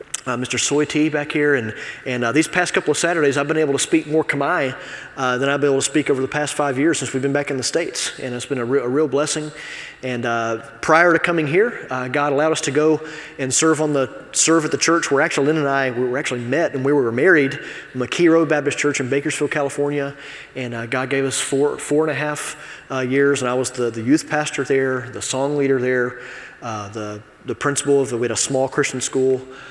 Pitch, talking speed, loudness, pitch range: 140 Hz, 250 wpm, -19 LUFS, 130-150 Hz